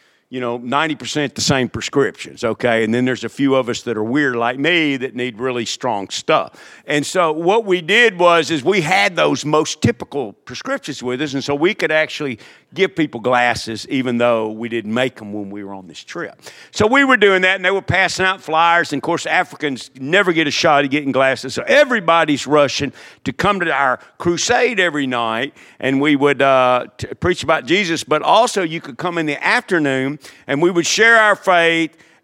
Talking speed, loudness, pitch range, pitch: 210 wpm, -16 LUFS, 125-170 Hz, 145 Hz